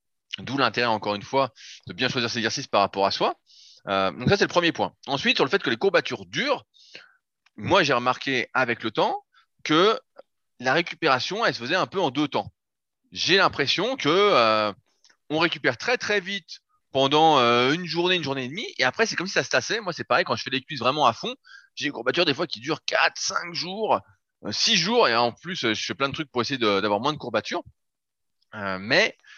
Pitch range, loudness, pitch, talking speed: 115-185 Hz, -23 LUFS, 140 Hz, 225 wpm